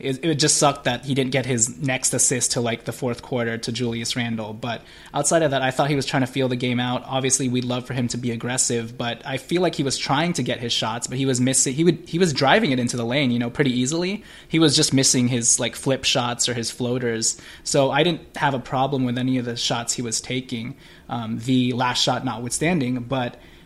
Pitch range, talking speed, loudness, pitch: 120-140 Hz, 255 wpm, -21 LUFS, 130 Hz